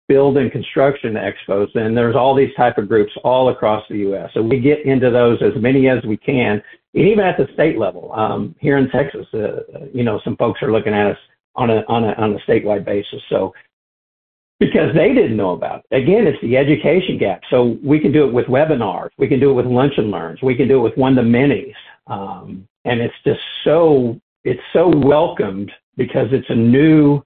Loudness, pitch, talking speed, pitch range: -16 LUFS, 125 Hz, 220 wpm, 110-135 Hz